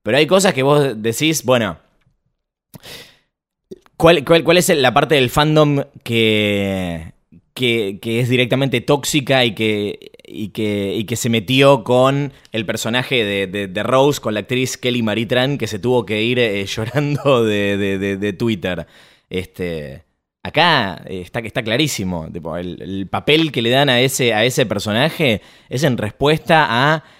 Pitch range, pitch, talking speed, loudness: 105-140 Hz, 120 Hz, 165 wpm, -16 LUFS